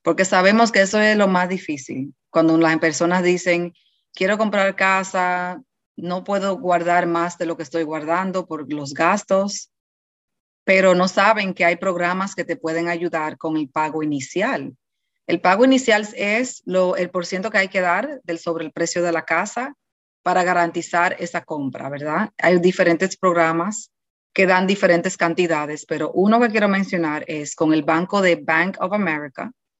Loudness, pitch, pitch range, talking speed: -19 LUFS, 180 Hz, 165-195 Hz, 170 wpm